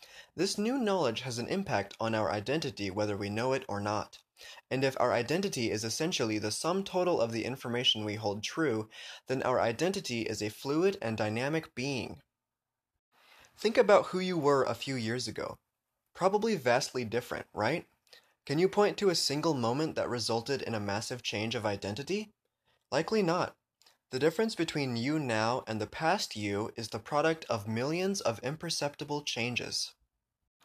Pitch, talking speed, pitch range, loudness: 125 Hz, 170 wpm, 110-165 Hz, -32 LUFS